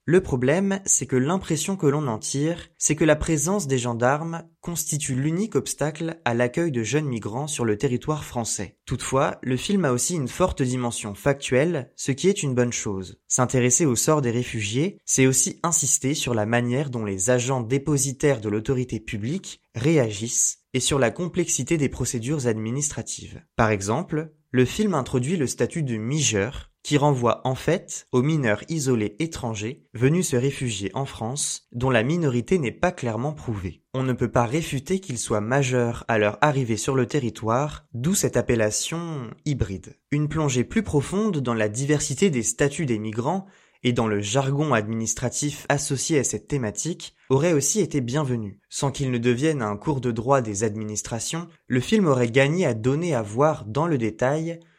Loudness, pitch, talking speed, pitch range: -24 LUFS, 135 Hz, 175 wpm, 120-155 Hz